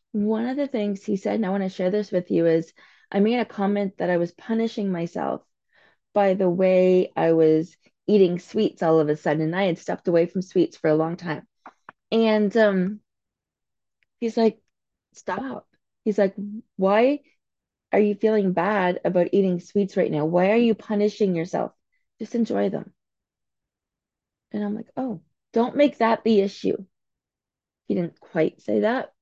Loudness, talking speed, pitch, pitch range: -23 LUFS, 175 wpm, 200 Hz, 180-220 Hz